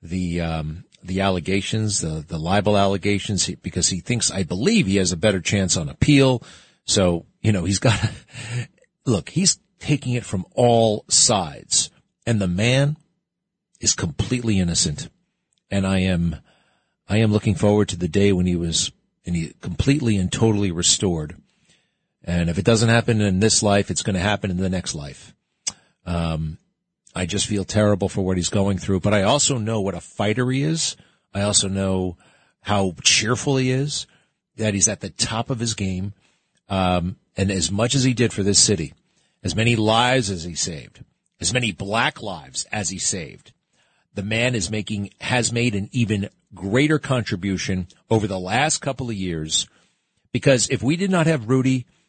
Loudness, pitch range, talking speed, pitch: -21 LUFS, 95-120 Hz, 175 wpm, 105 Hz